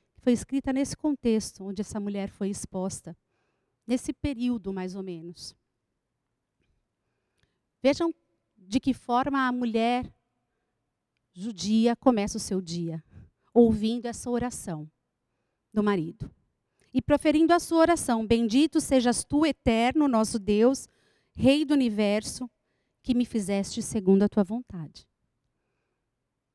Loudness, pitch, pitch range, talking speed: -26 LUFS, 230 Hz, 195-260 Hz, 115 wpm